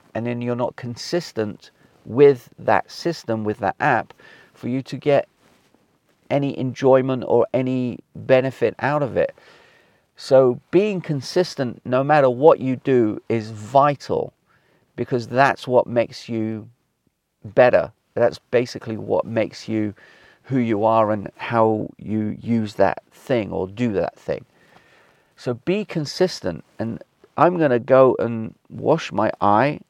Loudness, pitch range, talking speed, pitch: -21 LUFS, 115-140 Hz, 135 wpm, 125 Hz